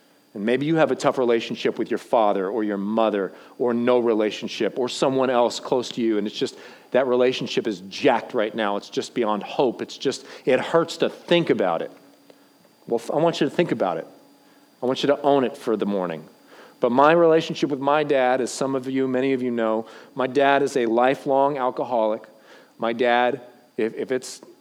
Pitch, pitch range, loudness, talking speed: 125 Hz, 115-140 Hz, -22 LUFS, 205 wpm